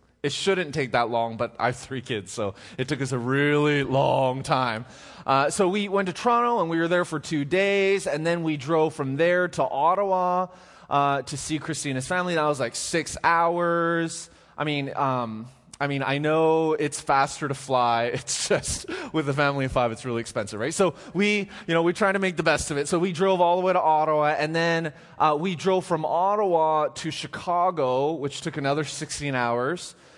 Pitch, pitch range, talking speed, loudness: 155 Hz, 135-175 Hz, 215 wpm, -24 LUFS